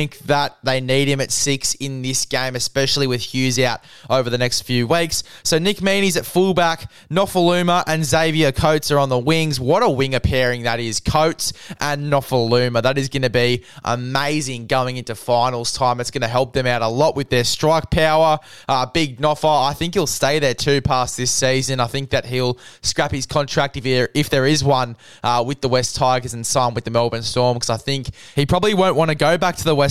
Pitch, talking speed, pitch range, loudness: 135 Hz, 220 wpm, 125-150 Hz, -18 LUFS